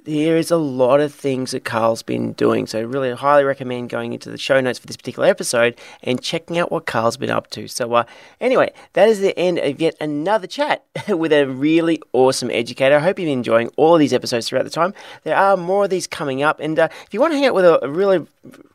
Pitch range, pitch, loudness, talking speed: 125-175 Hz, 150 Hz, -18 LUFS, 250 wpm